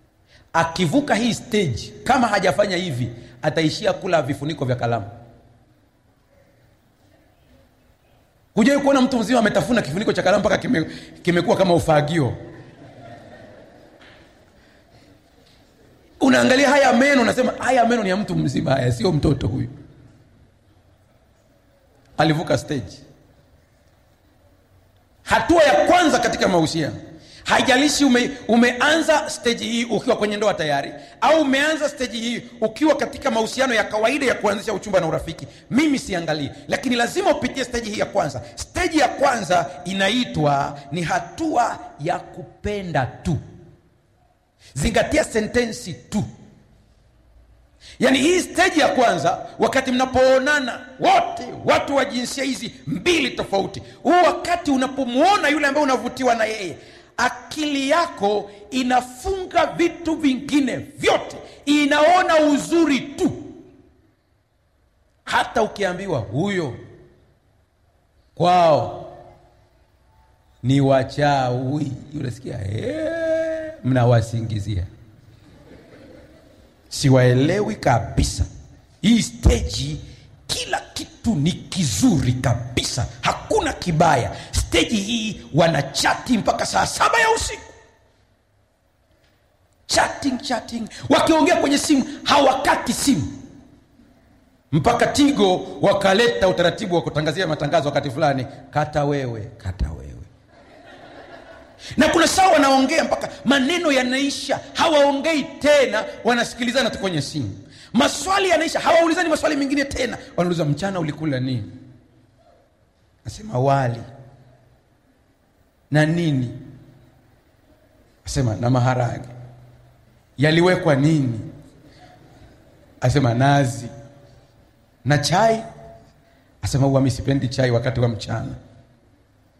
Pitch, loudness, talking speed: 175 Hz, -20 LUFS, 95 wpm